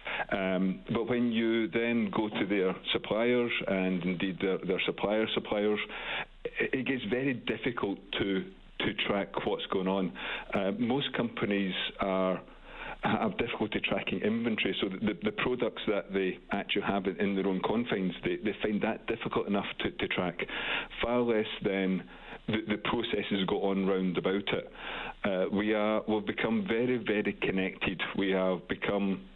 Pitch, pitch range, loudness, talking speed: 100 Hz, 95-110 Hz, -31 LUFS, 165 wpm